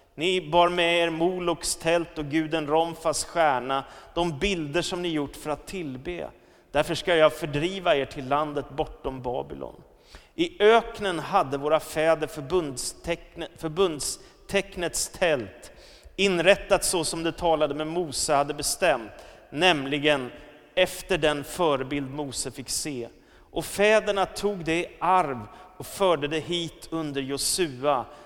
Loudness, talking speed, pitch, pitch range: -25 LUFS, 135 wpm, 160 Hz, 150-175 Hz